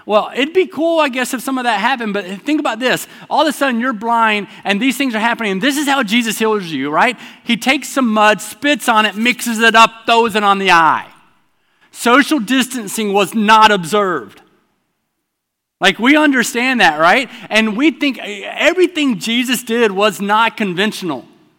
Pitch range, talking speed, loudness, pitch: 215-265 Hz, 190 wpm, -14 LUFS, 230 Hz